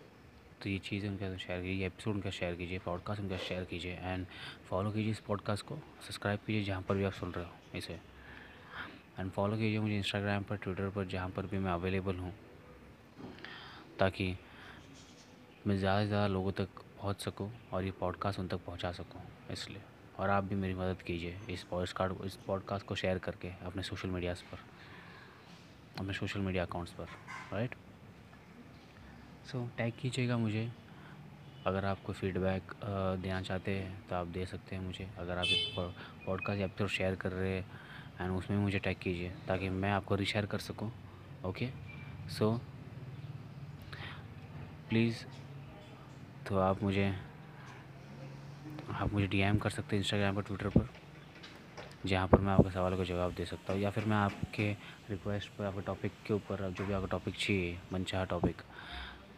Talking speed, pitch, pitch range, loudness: 165 wpm, 100 Hz, 95-110 Hz, -37 LUFS